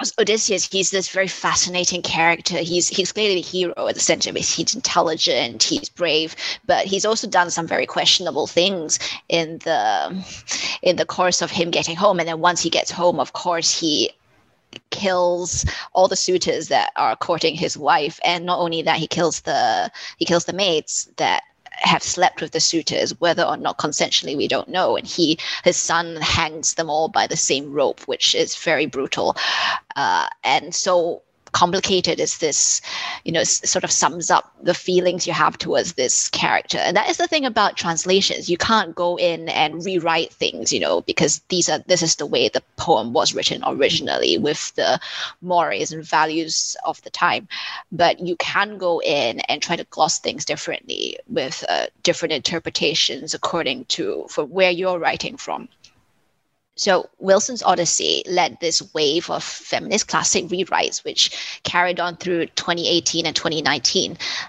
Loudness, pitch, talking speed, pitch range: -19 LUFS, 175 Hz, 175 wpm, 170-200 Hz